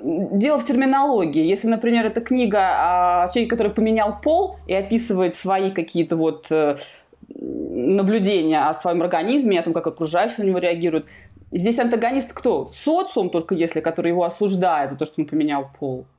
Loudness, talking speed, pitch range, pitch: -20 LUFS, 160 wpm, 165-230 Hz, 190 Hz